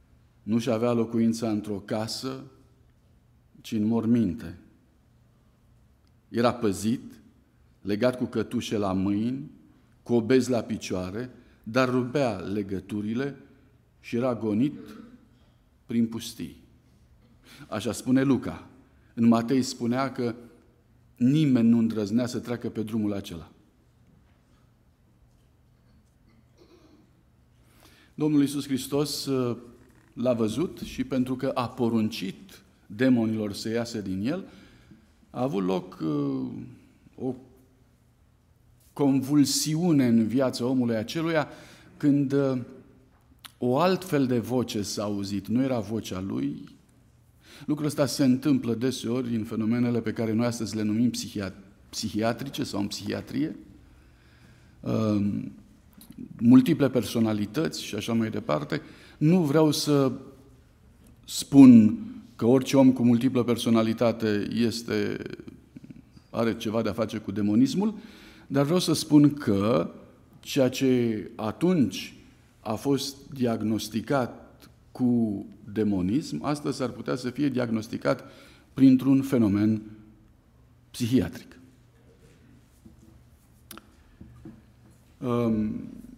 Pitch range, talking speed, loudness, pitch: 110-130 Hz, 100 wpm, -26 LUFS, 120 Hz